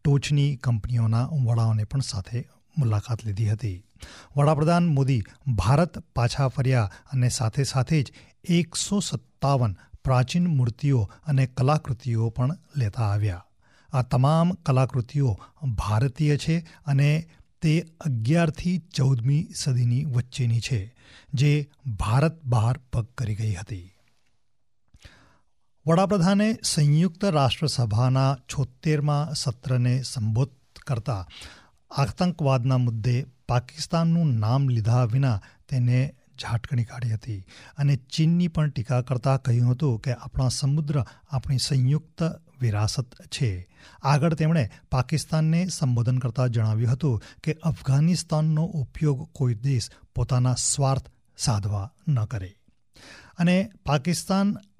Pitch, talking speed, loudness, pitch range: 130 Hz, 105 wpm, -25 LUFS, 120-150 Hz